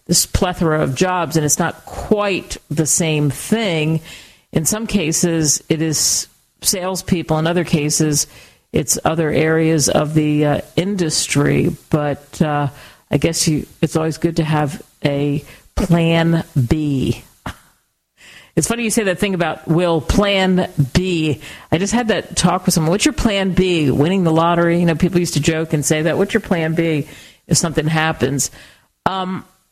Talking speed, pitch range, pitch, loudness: 165 wpm, 150-180 Hz, 165 Hz, -17 LUFS